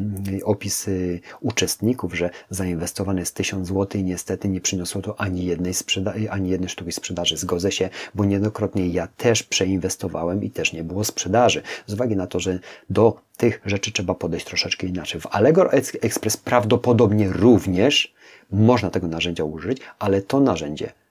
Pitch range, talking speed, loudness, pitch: 90-105 Hz, 155 wpm, -22 LUFS, 95 Hz